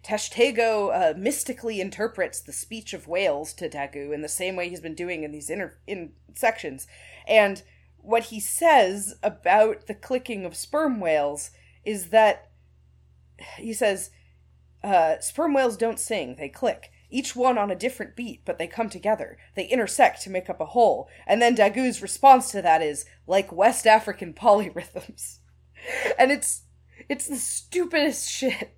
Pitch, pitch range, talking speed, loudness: 210 Hz, 165-240 Hz, 160 wpm, -24 LUFS